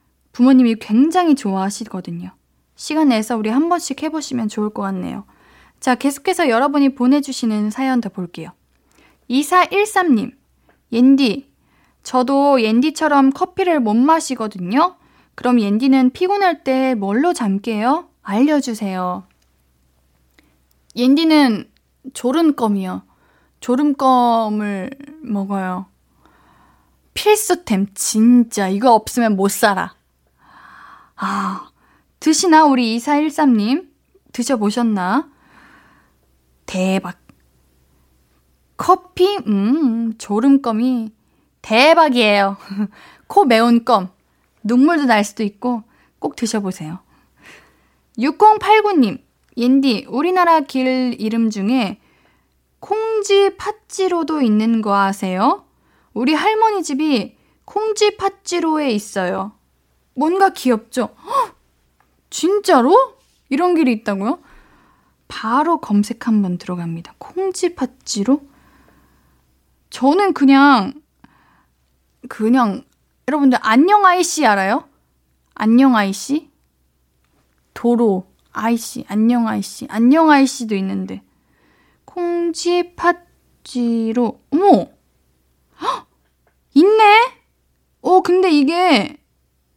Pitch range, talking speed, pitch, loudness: 200-310 Hz, 195 characters per minute, 245 Hz, -16 LUFS